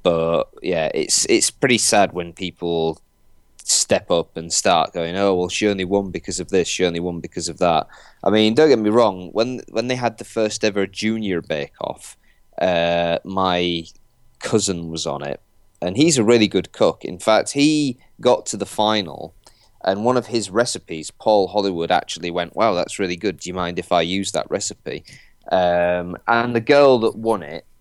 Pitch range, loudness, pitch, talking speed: 85-110 Hz, -19 LUFS, 95 Hz, 195 wpm